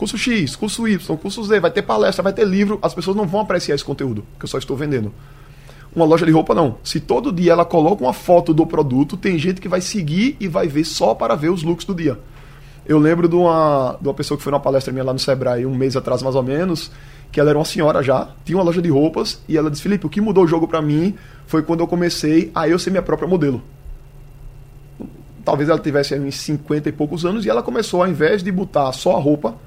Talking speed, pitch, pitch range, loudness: 250 wpm, 155 Hz, 140-180 Hz, -18 LUFS